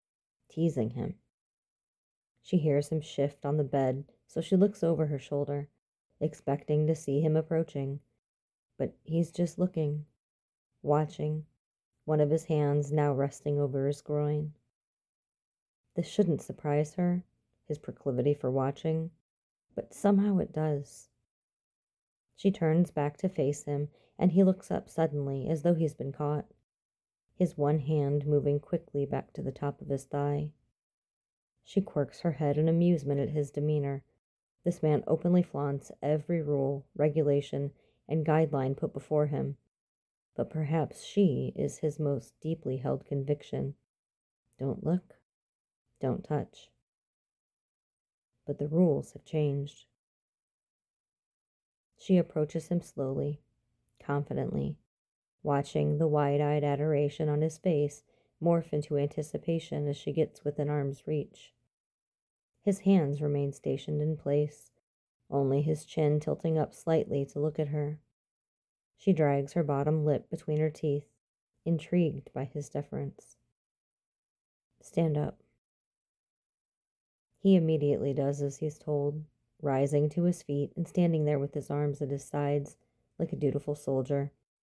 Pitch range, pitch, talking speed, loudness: 140-160 Hz, 150 Hz, 135 wpm, -31 LUFS